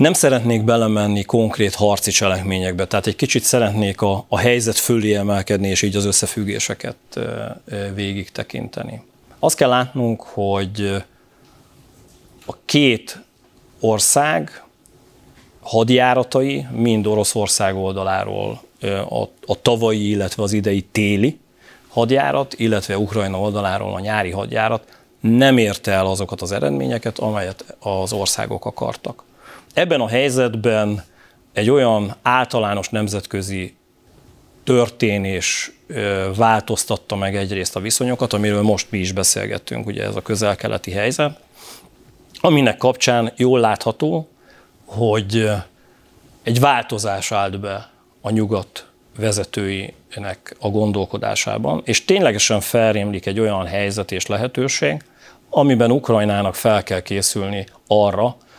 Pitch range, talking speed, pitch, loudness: 100-115 Hz, 110 wpm, 105 Hz, -18 LUFS